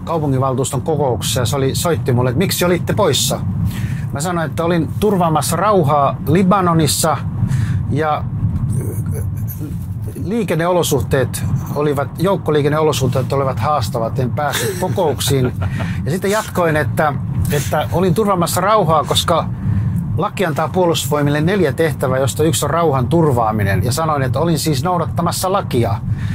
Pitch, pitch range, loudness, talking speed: 145 Hz, 125-165 Hz, -16 LUFS, 120 wpm